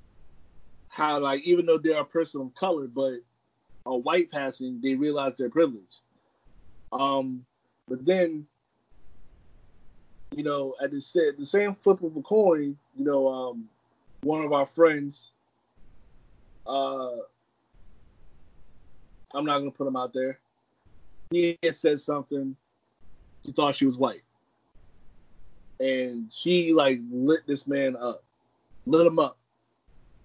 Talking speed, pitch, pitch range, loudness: 125 wpm, 135 Hz, 125-150 Hz, -26 LUFS